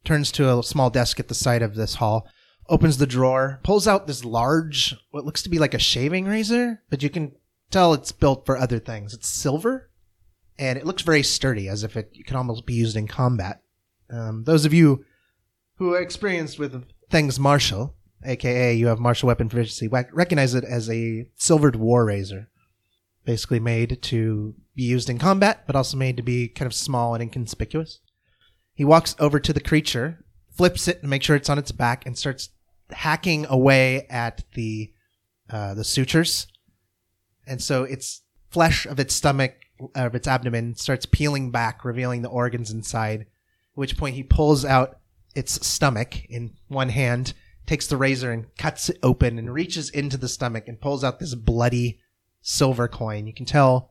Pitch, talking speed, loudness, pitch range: 125 Hz, 185 wpm, -22 LUFS, 115-145 Hz